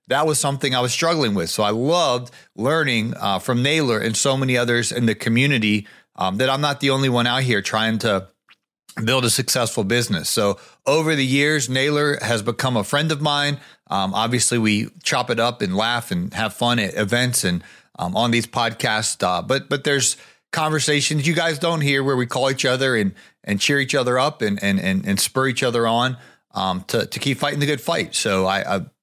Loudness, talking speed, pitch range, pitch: -20 LUFS, 215 wpm, 115-145 Hz, 125 Hz